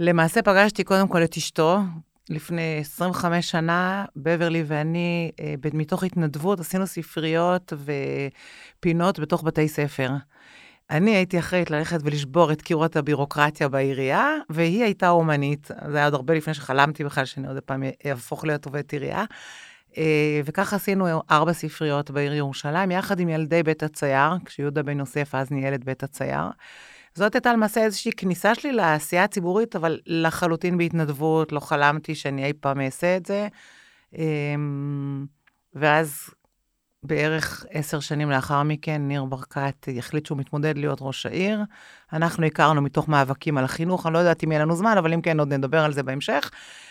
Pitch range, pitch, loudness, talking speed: 145-175 Hz, 155 Hz, -23 LUFS, 155 wpm